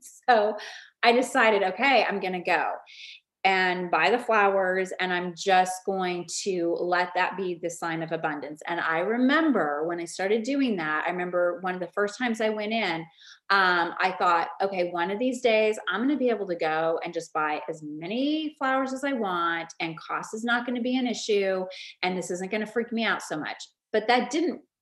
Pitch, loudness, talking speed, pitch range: 190 Hz, -26 LUFS, 215 wpm, 175-235 Hz